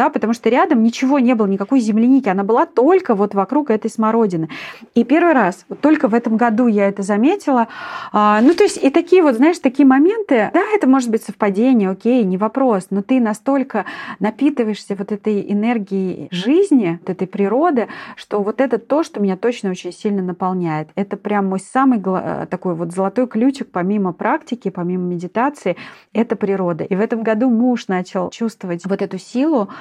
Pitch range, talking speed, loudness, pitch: 195-265 Hz, 180 wpm, -17 LUFS, 225 Hz